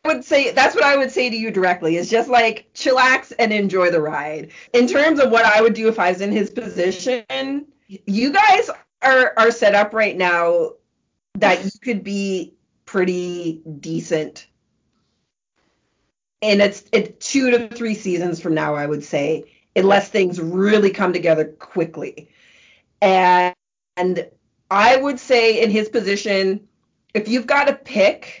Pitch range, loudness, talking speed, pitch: 180-245 Hz, -17 LUFS, 165 wpm, 210 Hz